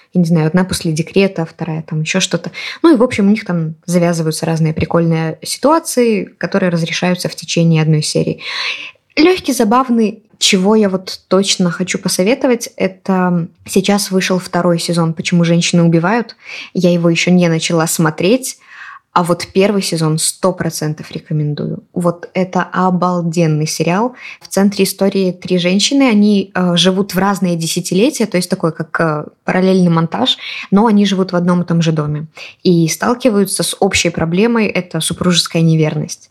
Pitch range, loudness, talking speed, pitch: 165-200 Hz, -14 LUFS, 155 wpm, 180 Hz